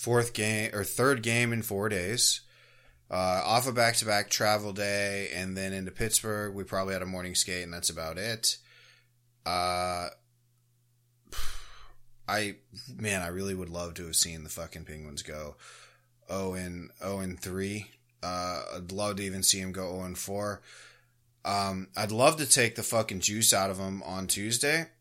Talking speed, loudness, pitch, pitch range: 165 wpm, -29 LUFS, 100 Hz, 90-115 Hz